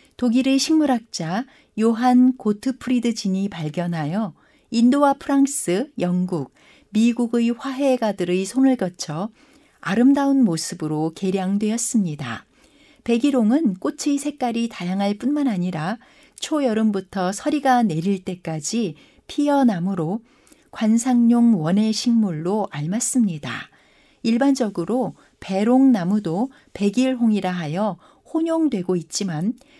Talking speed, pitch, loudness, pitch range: 255 characters per minute, 230 Hz, -21 LUFS, 190-260 Hz